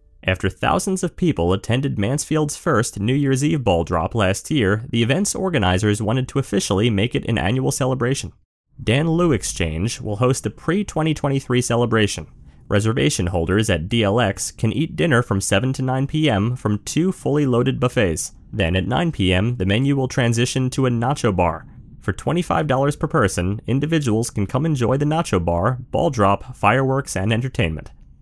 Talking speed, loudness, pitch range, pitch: 165 wpm, -20 LUFS, 100-140 Hz, 120 Hz